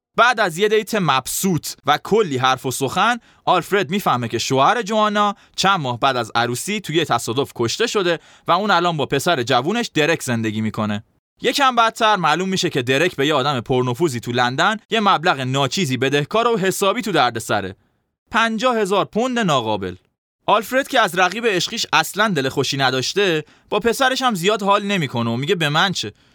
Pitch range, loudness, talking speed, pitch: 130-210 Hz, -18 LUFS, 180 wpm, 170 Hz